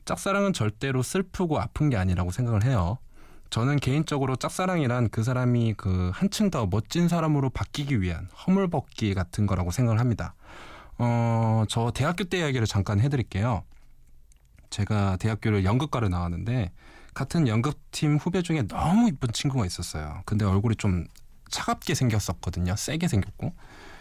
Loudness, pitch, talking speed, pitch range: -26 LUFS, 115 Hz, 345 characters per minute, 100-145 Hz